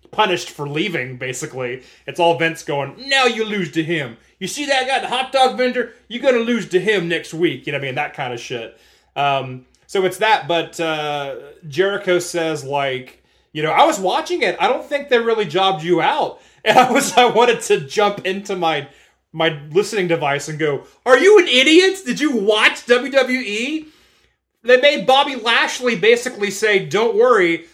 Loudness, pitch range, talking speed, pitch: -17 LUFS, 160-255 Hz, 195 wpm, 205 Hz